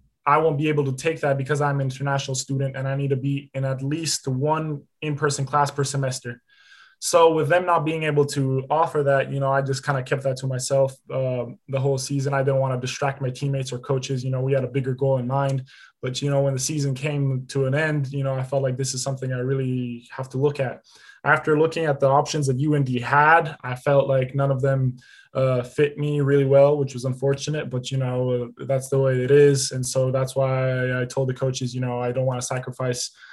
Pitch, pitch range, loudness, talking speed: 135 Hz, 130-145 Hz, -23 LUFS, 245 wpm